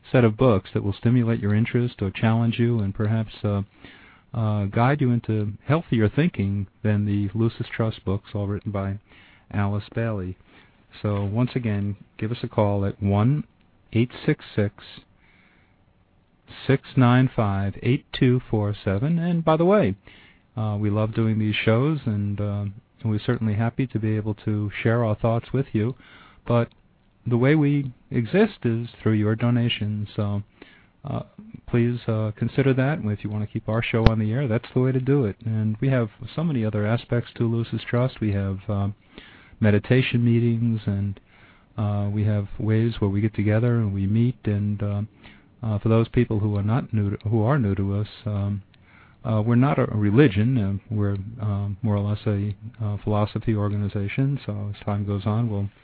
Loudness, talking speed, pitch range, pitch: -24 LUFS, 185 wpm, 100-120 Hz, 110 Hz